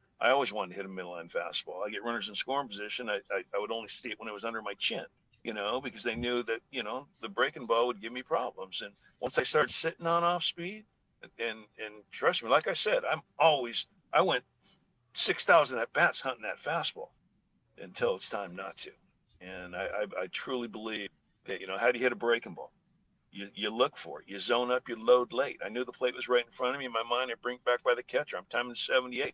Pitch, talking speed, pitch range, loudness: 120 Hz, 255 wpm, 110-125 Hz, -32 LUFS